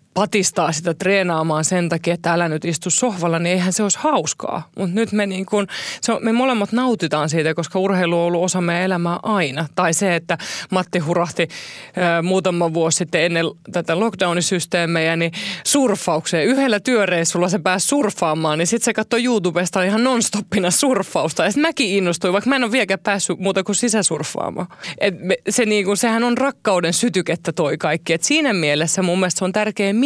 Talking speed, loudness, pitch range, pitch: 185 wpm, -18 LUFS, 170-210 Hz, 185 Hz